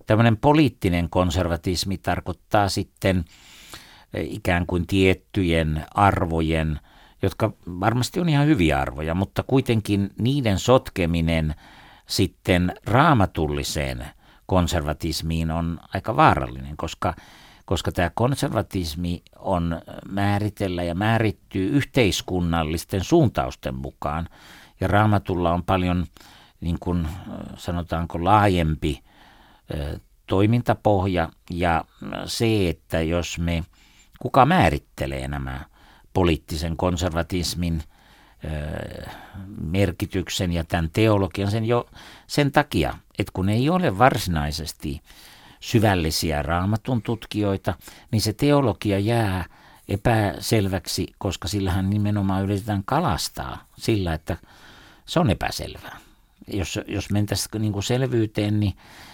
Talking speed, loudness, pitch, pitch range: 95 wpm, -23 LUFS, 95 Hz, 85-105 Hz